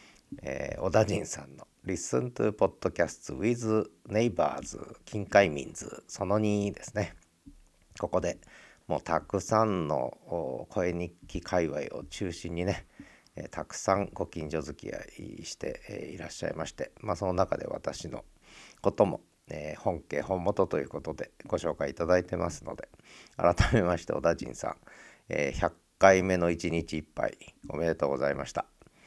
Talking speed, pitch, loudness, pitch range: 330 characters per minute, 90 Hz, -31 LUFS, 85-105 Hz